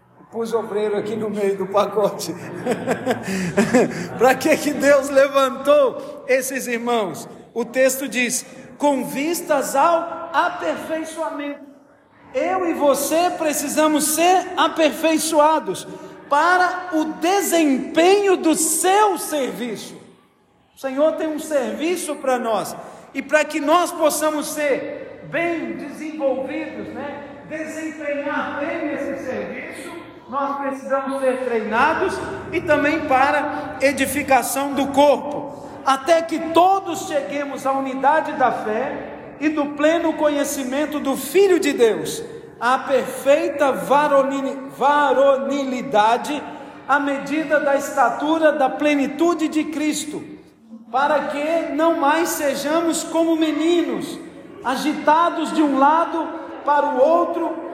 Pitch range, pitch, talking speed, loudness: 270-315 Hz, 290 Hz, 110 wpm, -19 LUFS